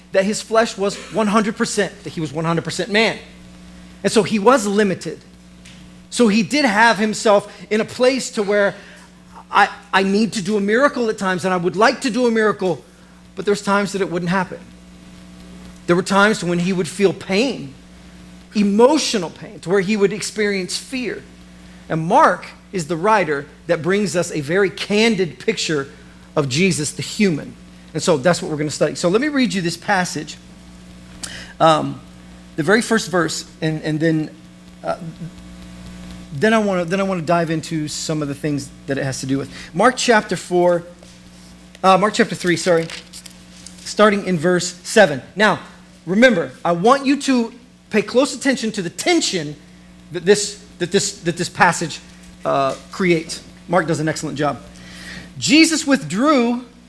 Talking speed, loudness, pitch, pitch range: 175 wpm, -18 LUFS, 180 Hz, 140-210 Hz